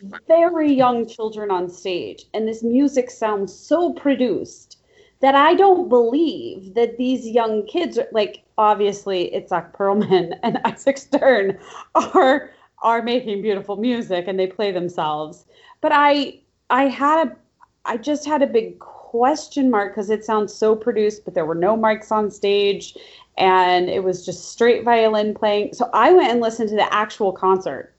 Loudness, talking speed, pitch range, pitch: -19 LUFS, 165 wpm, 200-275 Hz, 225 Hz